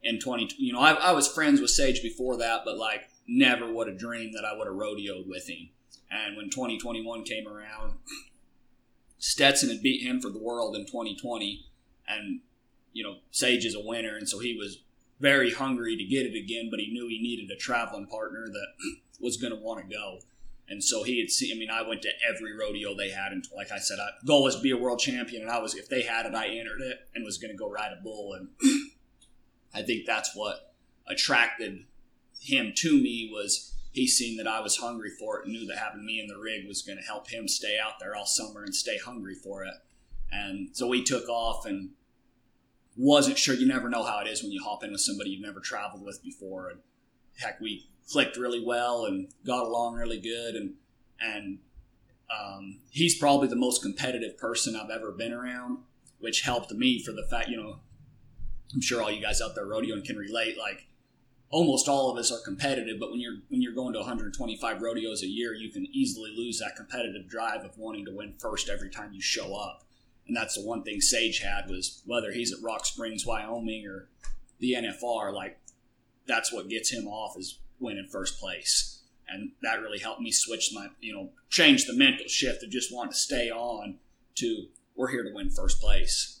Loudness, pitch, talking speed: -29 LUFS, 125 Hz, 215 wpm